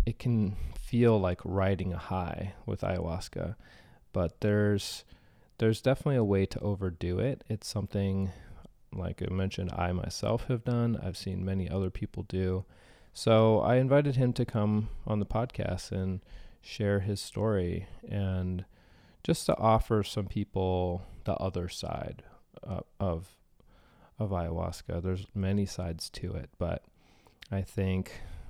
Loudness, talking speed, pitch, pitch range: -31 LUFS, 140 wpm, 95 Hz, 90-110 Hz